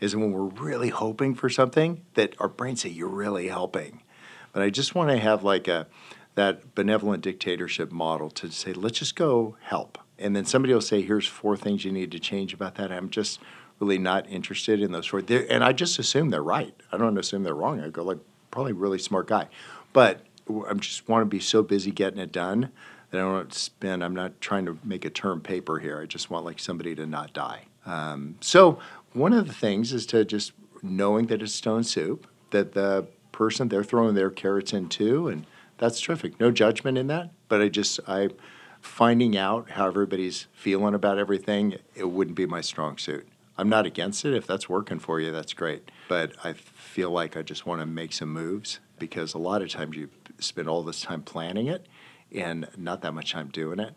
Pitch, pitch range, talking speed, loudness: 100 Hz, 95-110 Hz, 220 wpm, -26 LUFS